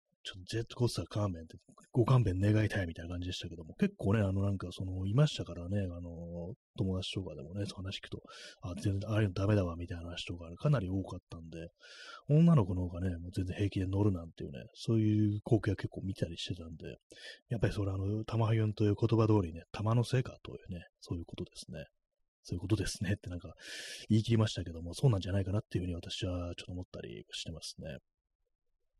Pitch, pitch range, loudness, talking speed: 100 Hz, 90-110 Hz, -34 LUFS, 470 characters per minute